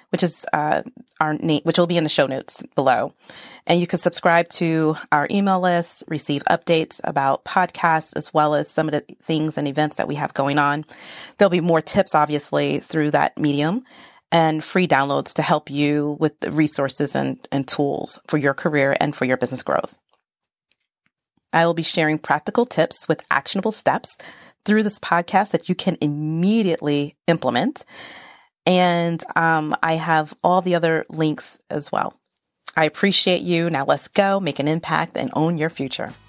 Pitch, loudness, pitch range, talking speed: 160 Hz, -20 LUFS, 150-175 Hz, 175 wpm